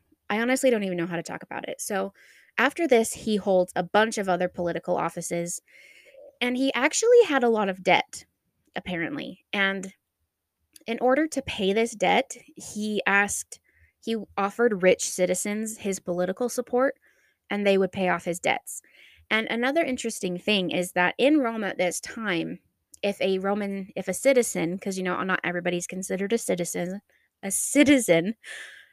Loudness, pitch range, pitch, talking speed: -25 LUFS, 180-230 Hz, 195 Hz, 165 wpm